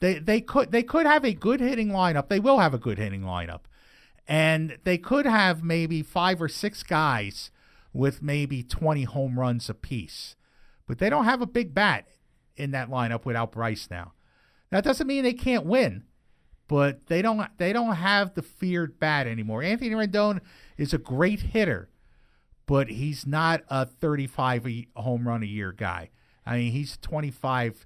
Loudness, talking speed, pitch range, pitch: -26 LUFS, 175 wpm, 120-200 Hz, 155 Hz